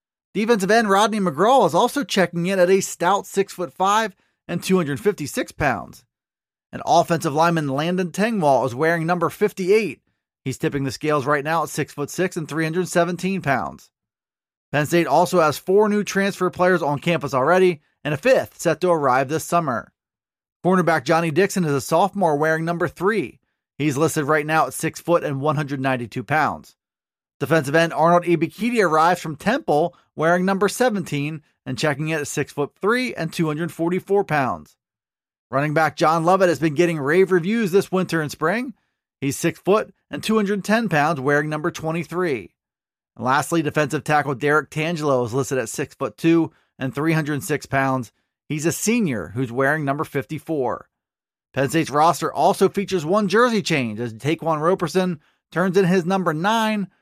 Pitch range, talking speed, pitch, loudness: 150-185 Hz, 155 wpm, 165 Hz, -20 LUFS